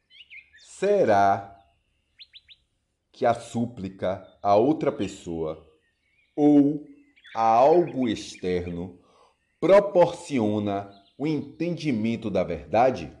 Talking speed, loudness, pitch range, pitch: 75 wpm, -24 LUFS, 90-145 Hz, 105 Hz